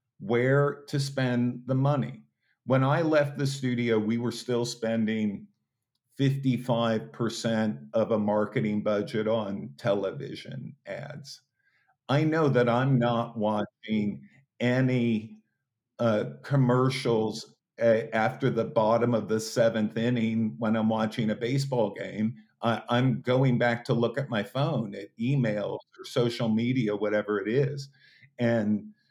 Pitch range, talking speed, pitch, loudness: 110-130 Hz, 130 wpm, 120 Hz, -27 LUFS